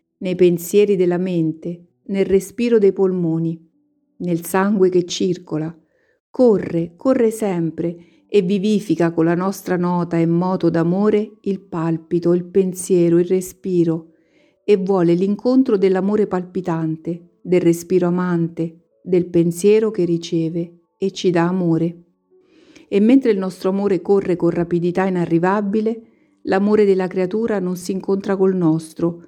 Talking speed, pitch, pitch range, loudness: 130 wpm, 180 Hz, 170-200 Hz, -18 LUFS